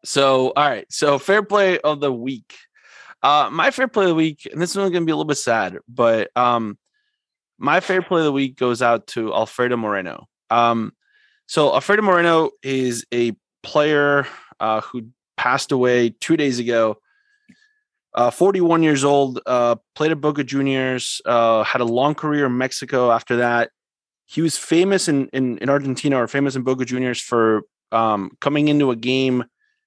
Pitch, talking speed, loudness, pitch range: 140 Hz, 175 wpm, -19 LUFS, 120-165 Hz